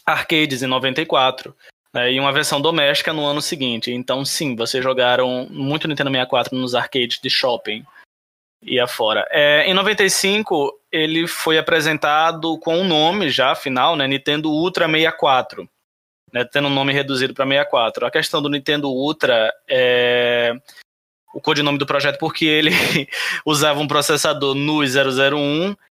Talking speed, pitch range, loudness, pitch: 150 wpm, 130-155 Hz, -17 LUFS, 145 Hz